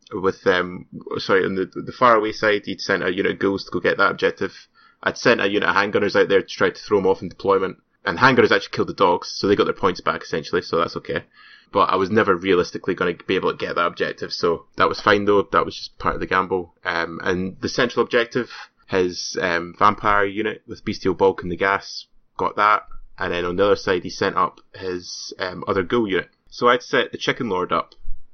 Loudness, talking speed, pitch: -21 LUFS, 245 wpm, 100 Hz